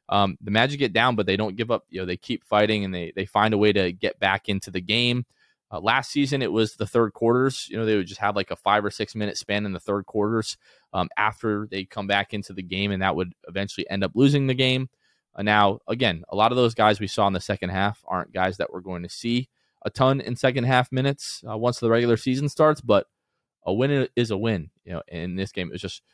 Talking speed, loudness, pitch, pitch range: 265 wpm, -24 LUFS, 105 Hz, 100-120 Hz